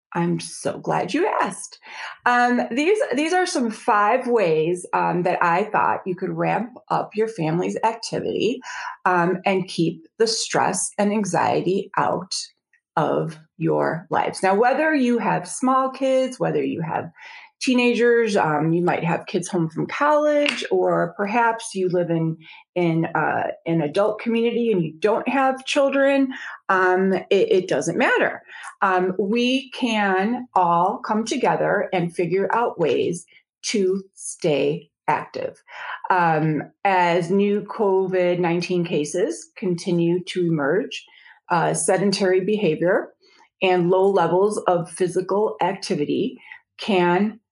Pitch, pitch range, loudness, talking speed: 195 Hz, 180-255 Hz, -21 LUFS, 130 wpm